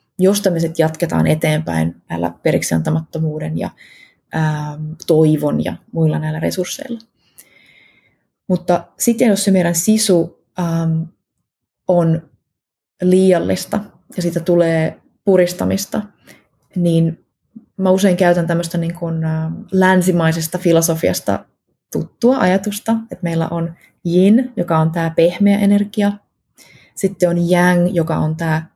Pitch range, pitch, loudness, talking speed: 160-190 Hz, 170 Hz, -16 LUFS, 105 wpm